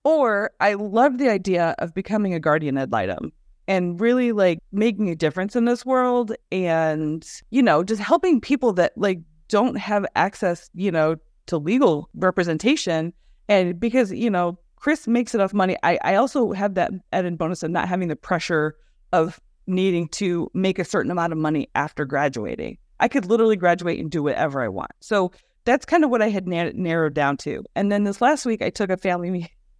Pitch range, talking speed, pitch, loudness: 170-230 Hz, 195 wpm, 185 Hz, -22 LUFS